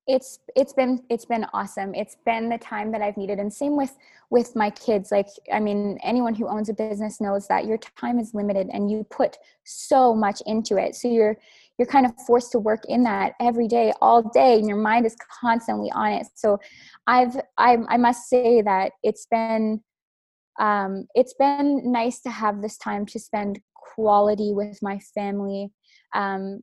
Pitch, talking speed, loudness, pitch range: 220 Hz, 190 wpm, -23 LUFS, 205-240 Hz